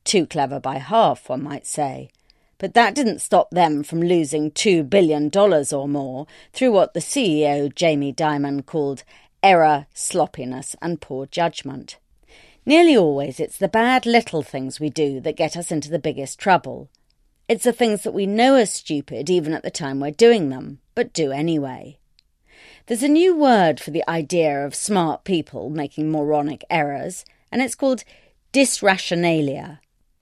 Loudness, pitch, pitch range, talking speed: -20 LUFS, 160 Hz, 145-200 Hz, 165 wpm